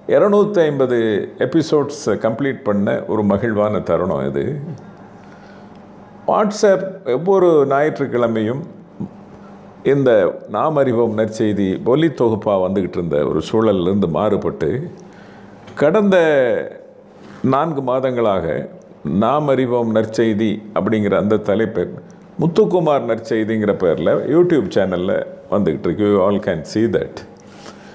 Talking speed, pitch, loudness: 90 wpm, 130 Hz, -17 LUFS